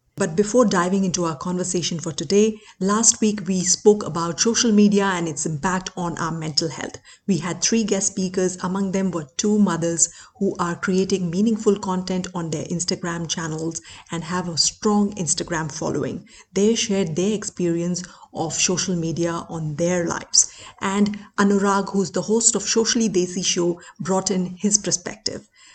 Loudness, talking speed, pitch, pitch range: -21 LUFS, 165 wpm, 185 Hz, 170-205 Hz